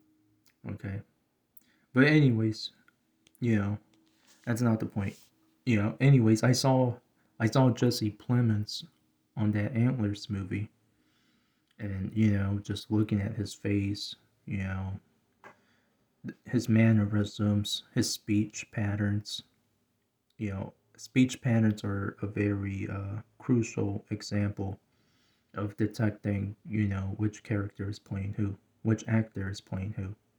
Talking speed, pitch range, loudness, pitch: 120 wpm, 100-115 Hz, -30 LUFS, 105 Hz